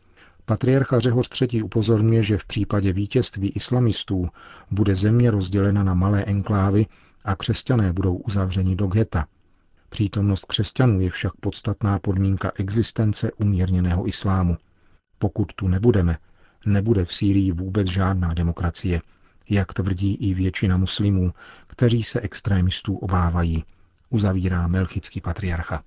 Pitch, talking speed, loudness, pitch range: 95 Hz, 120 wpm, -22 LUFS, 90-105 Hz